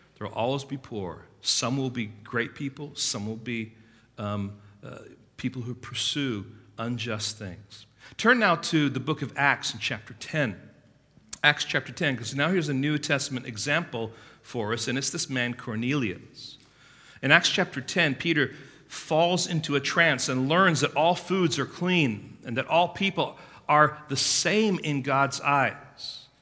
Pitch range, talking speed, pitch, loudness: 115-150 Hz, 165 wpm, 135 Hz, -26 LUFS